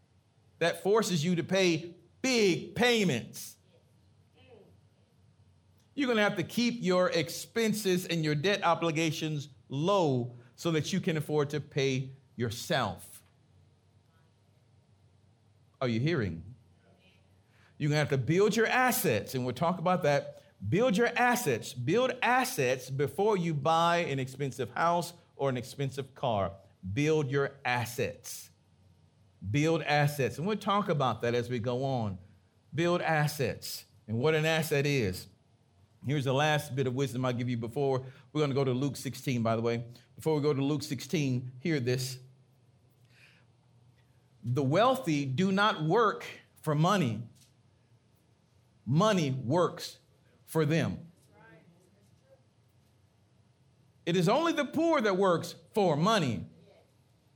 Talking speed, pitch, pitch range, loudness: 130 wpm, 135 Hz, 115-165 Hz, -30 LUFS